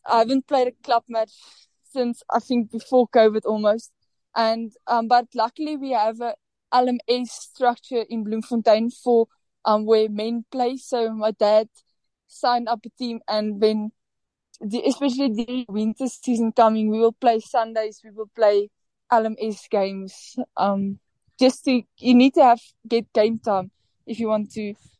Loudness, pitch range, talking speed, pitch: -22 LUFS, 215-245 Hz, 160 wpm, 230 Hz